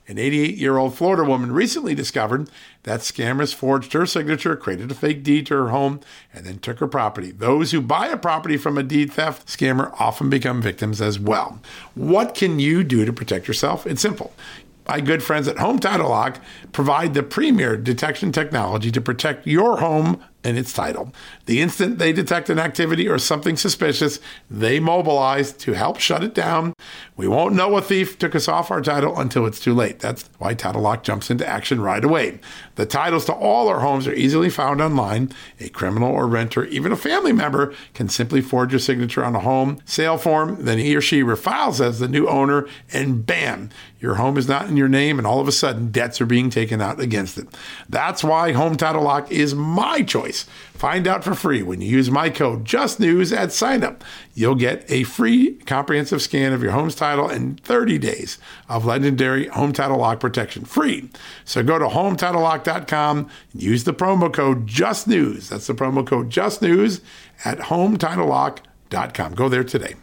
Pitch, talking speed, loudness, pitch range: 140 Hz, 190 wpm, -20 LUFS, 125-155 Hz